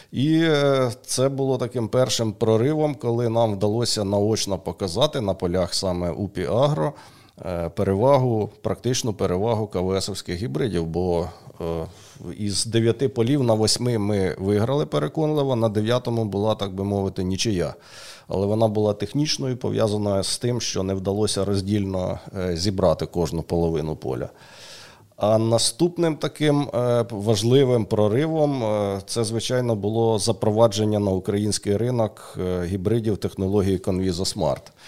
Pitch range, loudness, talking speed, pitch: 95-120 Hz, -23 LUFS, 115 wpm, 105 Hz